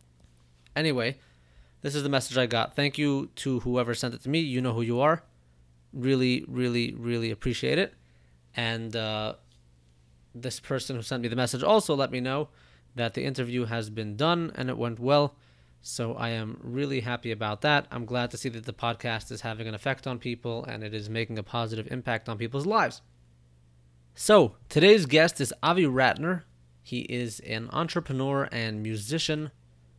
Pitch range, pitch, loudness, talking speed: 100-130 Hz, 120 Hz, -28 LUFS, 180 wpm